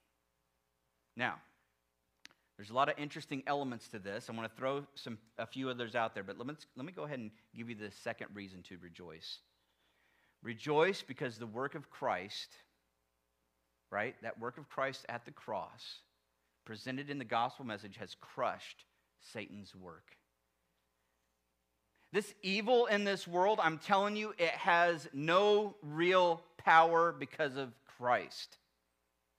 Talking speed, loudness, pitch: 150 wpm, -35 LUFS, 115 Hz